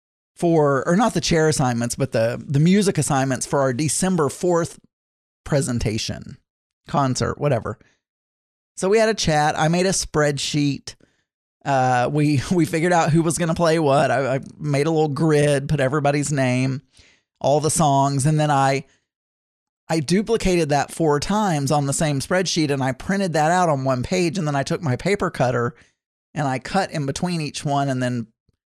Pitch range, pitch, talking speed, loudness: 130-165 Hz, 145 Hz, 175 wpm, -20 LUFS